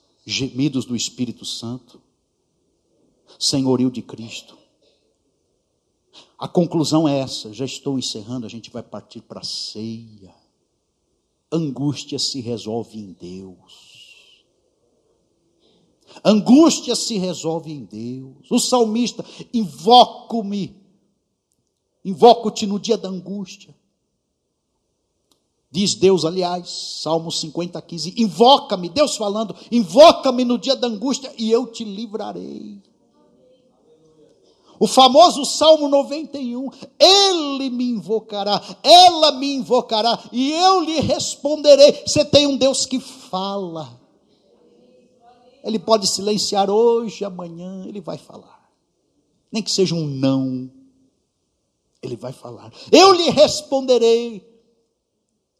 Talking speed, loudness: 105 wpm, -17 LUFS